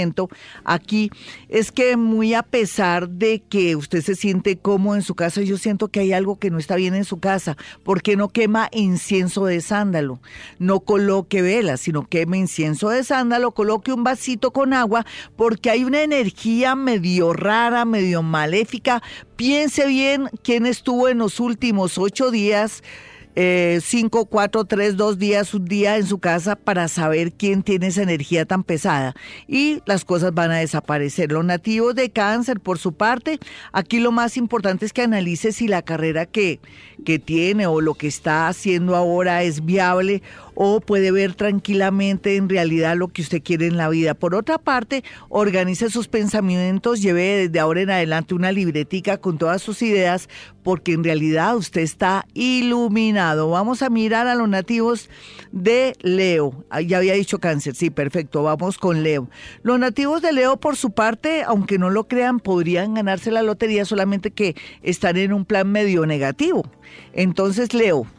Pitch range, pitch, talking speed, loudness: 175-225 Hz, 195 Hz, 170 wpm, -19 LUFS